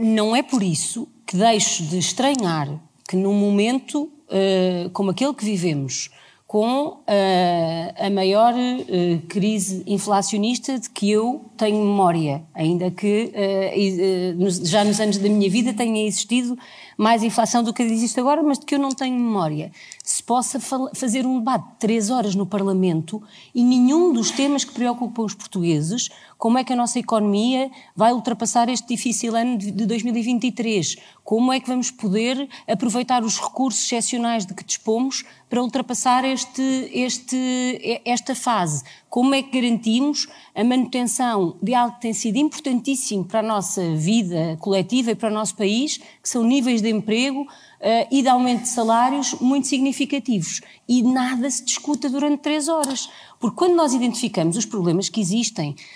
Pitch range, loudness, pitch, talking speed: 200-255 Hz, -21 LUFS, 230 Hz, 155 wpm